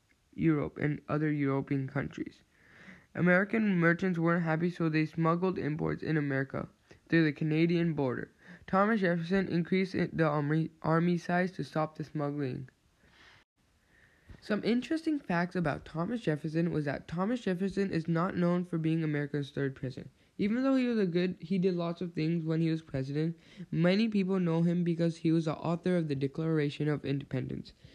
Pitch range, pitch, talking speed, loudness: 150-180 Hz, 165 Hz, 165 wpm, -31 LUFS